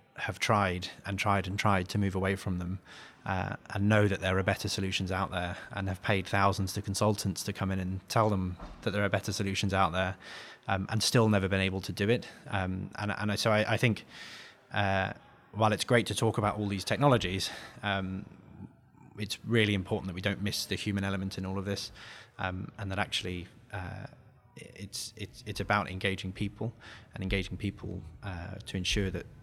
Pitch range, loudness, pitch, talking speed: 95-105 Hz, -31 LUFS, 100 Hz, 205 wpm